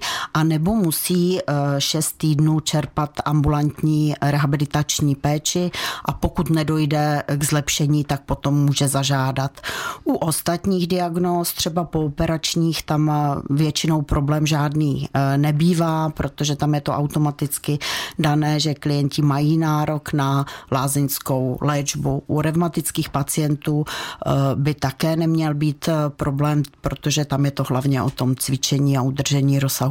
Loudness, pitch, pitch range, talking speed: -20 LUFS, 150 Hz, 140-155 Hz, 120 wpm